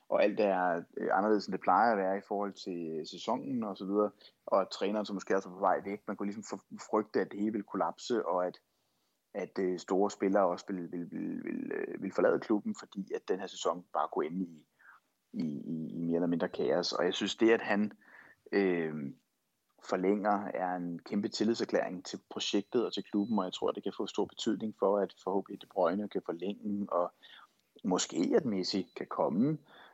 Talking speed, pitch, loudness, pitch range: 200 wpm, 95 Hz, -33 LUFS, 90-105 Hz